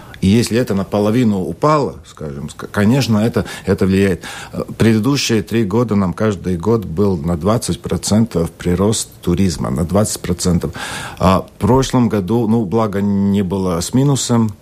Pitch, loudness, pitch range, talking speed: 105 Hz, -16 LUFS, 90-115 Hz, 135 wpm